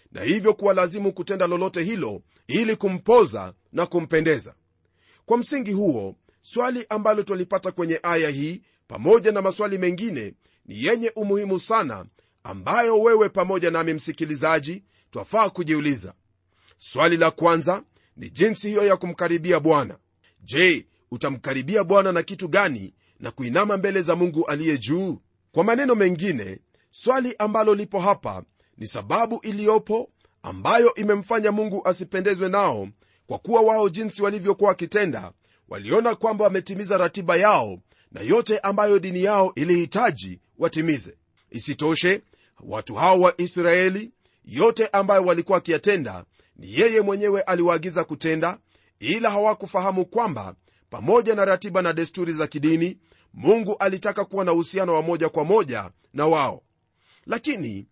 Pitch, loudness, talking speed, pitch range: 185 Hz, -22 LUFS, 130 wpm, 160-205 Hz